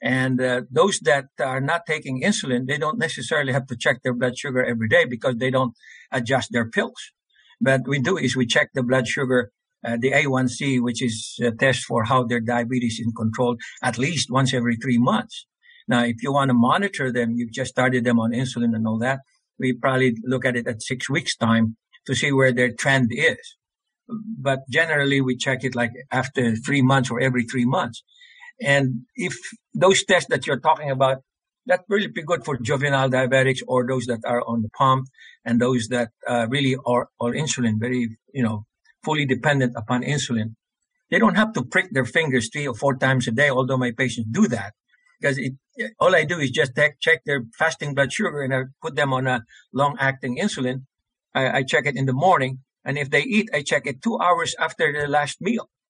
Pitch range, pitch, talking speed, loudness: 120-140 Hz, 130 Hz, 205 wpm, -22 LUFS